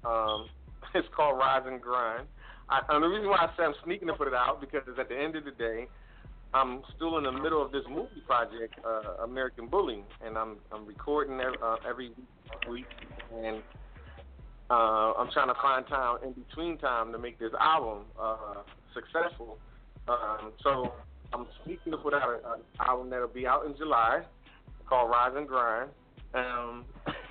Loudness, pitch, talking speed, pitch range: -31 LUFS, 125 Hz, 180 wpm, 115-140 Hz